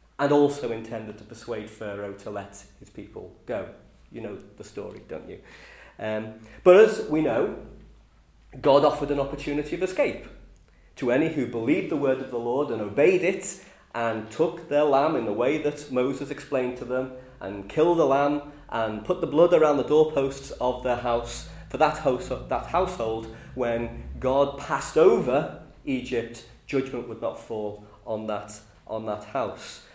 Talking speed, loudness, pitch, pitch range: 165 wpm, -25 LUFS, 125 Hz, 110-145 Hz